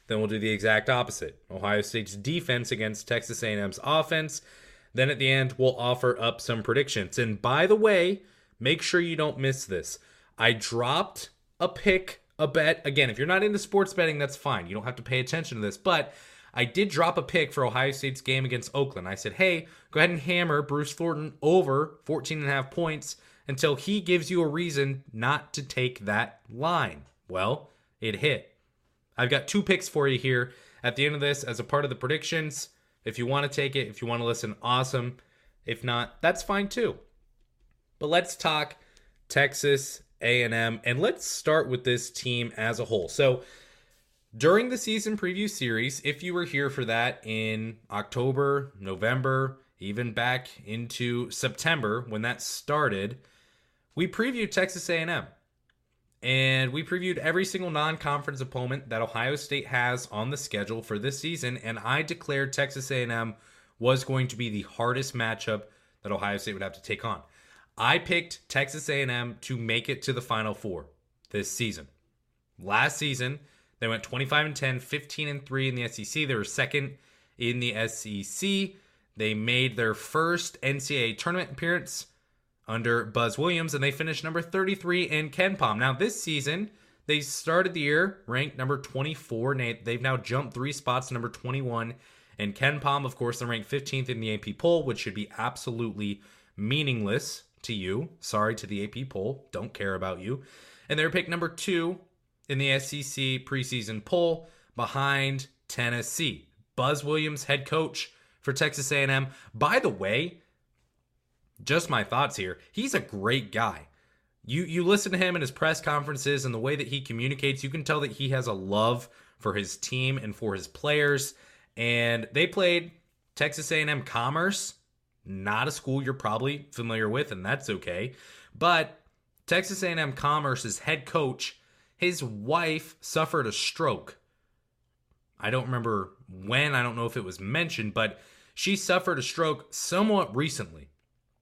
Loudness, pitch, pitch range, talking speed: -28 LUFS, 135 Hz, 115-155 Hz, 175 wpm